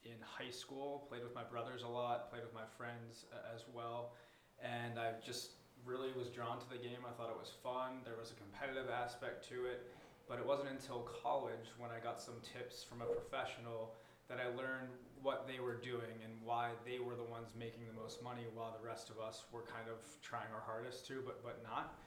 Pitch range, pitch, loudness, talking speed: 115-125 Hz, 120 Hz, -47 LUFS, 225 wpm